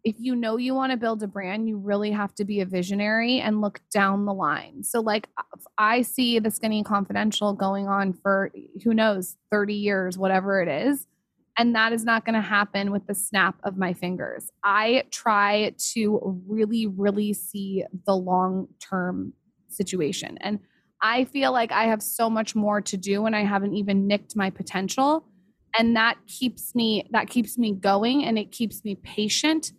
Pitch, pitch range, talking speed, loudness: 210 Hz, 195-225 Hz, 185 wpm, -24 LUFS